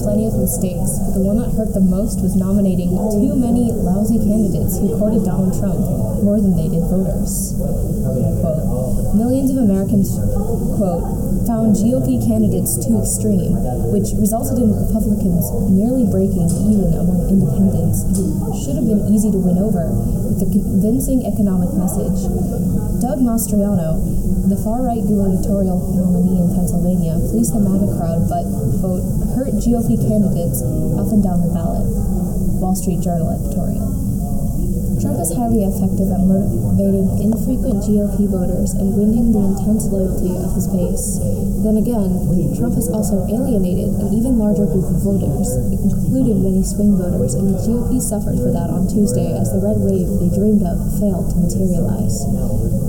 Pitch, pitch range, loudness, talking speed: 190 Hz, 180-210 Hz, -17 LUFS, 150 wpm